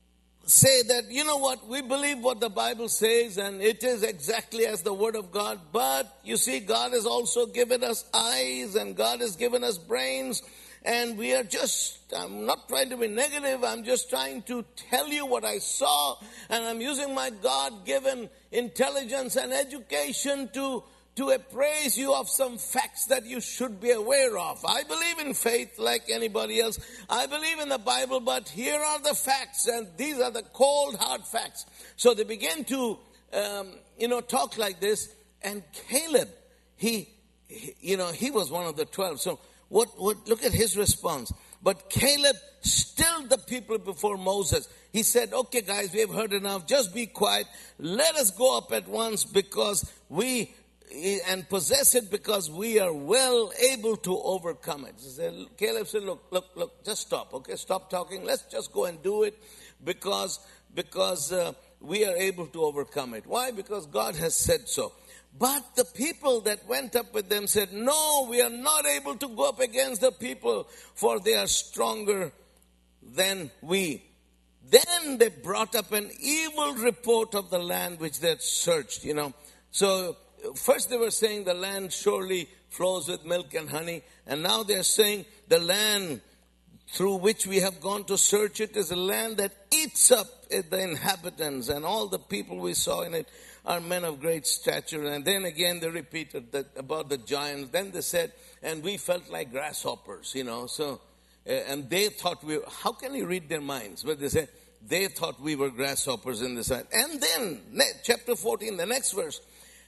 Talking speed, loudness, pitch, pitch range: 185 wpm, -27 LUFS, 225 Hz, 185-260 Hz